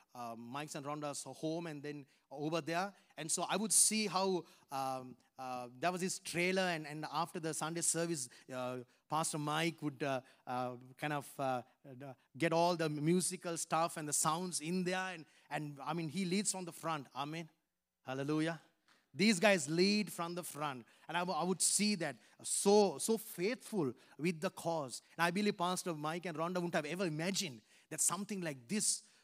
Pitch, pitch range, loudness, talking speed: 165 Hz, 145-180 Hz, -37 LUFS, 185 wpm